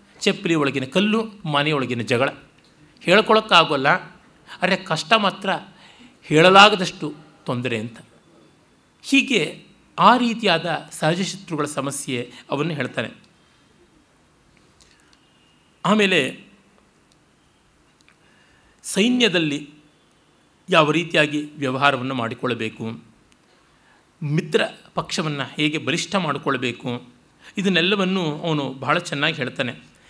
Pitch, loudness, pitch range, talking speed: 155 Hz, -20 LUFS, 135-185 Hz, 70 wpm